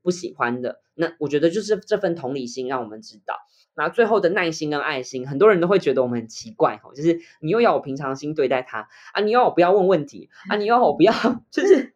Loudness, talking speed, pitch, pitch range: -21 LUFS, 365 characters per minute, 165 Hz, 130-210 Hz